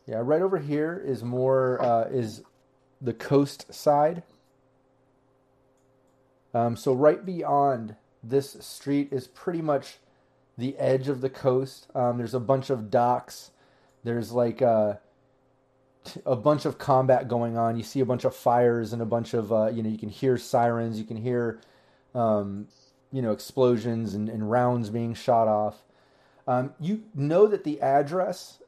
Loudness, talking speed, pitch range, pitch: -26 LUFS, 160 wpm, 115-135 Hz, 130 Hz